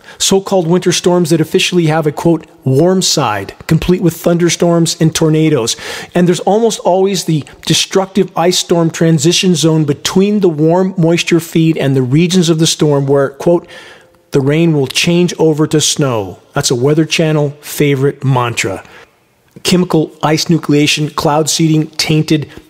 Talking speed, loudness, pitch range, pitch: 155 wpm, -12 LUFS, 150-175 Hz, 160 Hz